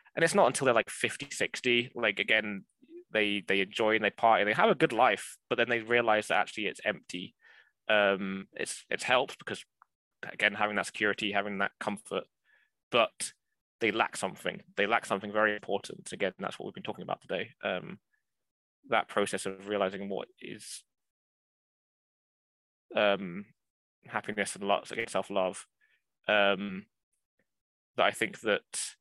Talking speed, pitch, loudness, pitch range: 155 wpm, 105 Hz, -30 LUFS, 100-110 Hz